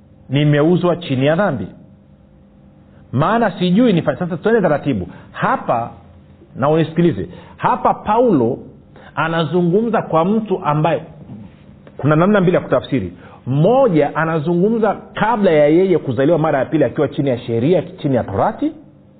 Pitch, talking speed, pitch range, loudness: 155 Hz, 120 wpm, 135-180 Hz, -16 LUFS